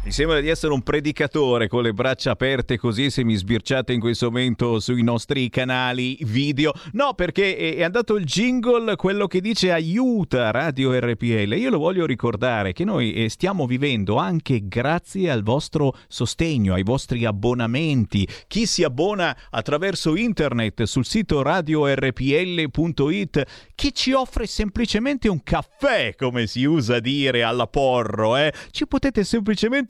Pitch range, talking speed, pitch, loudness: 120-180 Hz, 145 wpm, 140 Hz, -21 LUFS